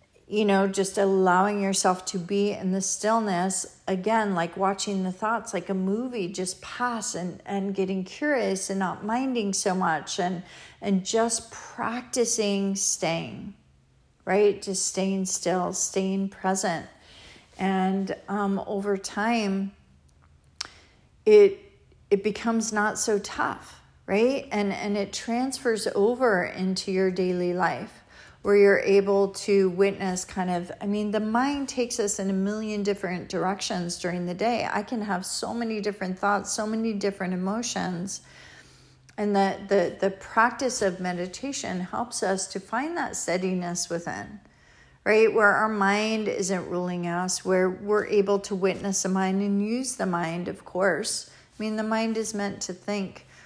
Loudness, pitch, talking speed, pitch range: -26 LUFS, 200 Hz, 150 wpm, 190-215 Hz